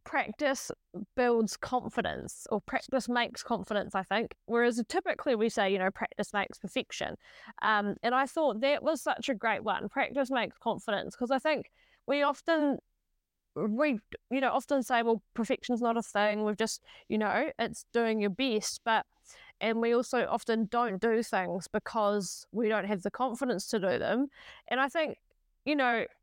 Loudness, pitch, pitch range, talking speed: -31 LUFS, 235 Hz, 210-265 Hz, 175 wpm